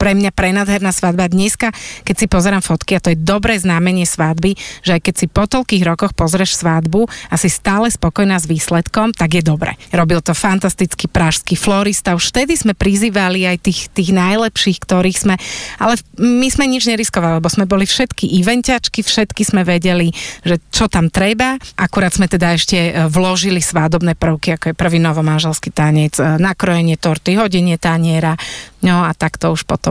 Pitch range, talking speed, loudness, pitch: 170-200 Hz, 175 wpm, -14 LUFS, 185 Hz